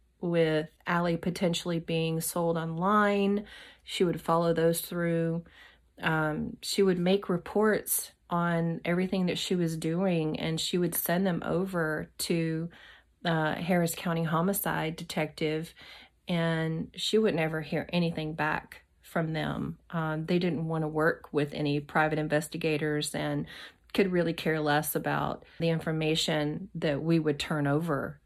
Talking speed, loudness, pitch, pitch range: 140 wpm, -29 LUFS, 165 Hz, 155-175 Hz